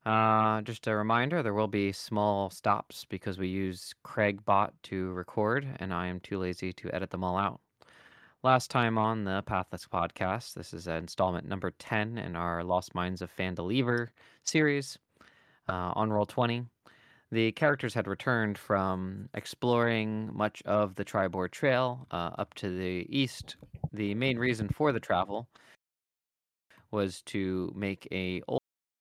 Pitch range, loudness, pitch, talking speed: 95-115 Hz, -31 LUFS, 105 Hz, 155 wpm